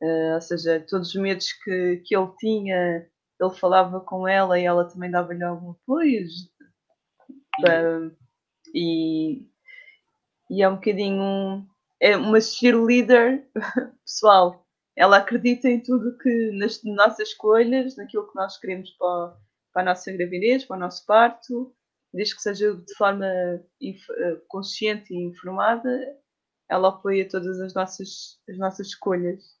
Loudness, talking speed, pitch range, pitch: -22 LUFS, 140 wpm, 180-235 Hz, 195 Hz